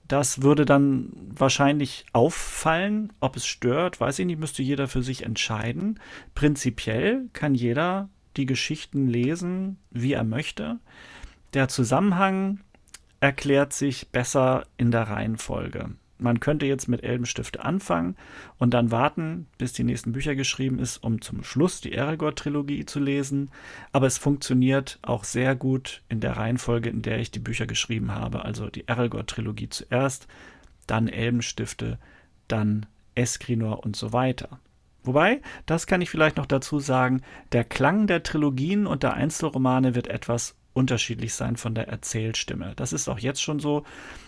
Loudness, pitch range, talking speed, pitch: -25 LUFS, 120-145 Hz, 150 wpm, 130 Hz